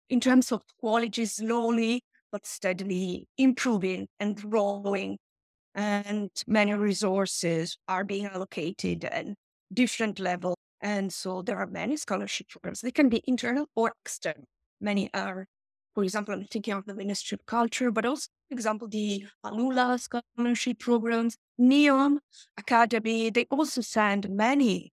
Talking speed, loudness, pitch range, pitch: 135 wpm, -28 LUFS, 200-240 Hz, 220 Hz